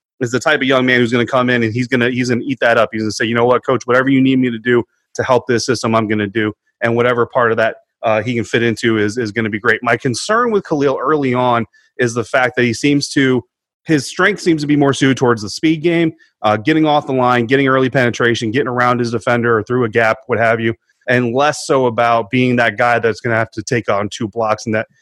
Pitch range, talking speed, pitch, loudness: 115-130 Hz, 290 wpm, 120 Hz, -15 LUFS